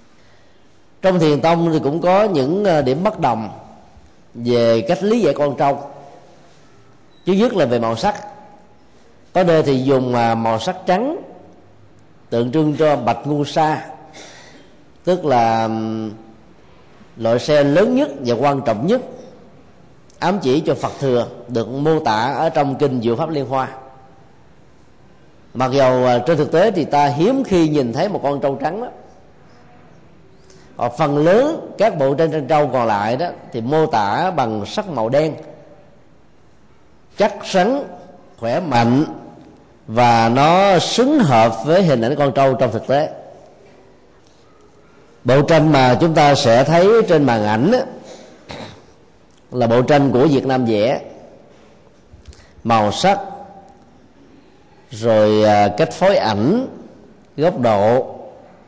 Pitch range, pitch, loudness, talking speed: 120-170 Hz, 145 Hz, -16 LUFS, 140 wpm